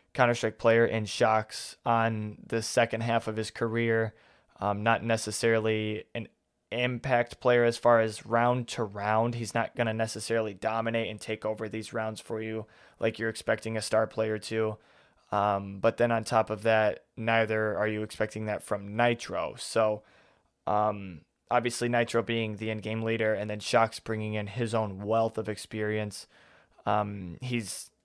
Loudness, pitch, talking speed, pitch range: -29 LUFS, 110 Hz, 165 wpm, 105-115 Hz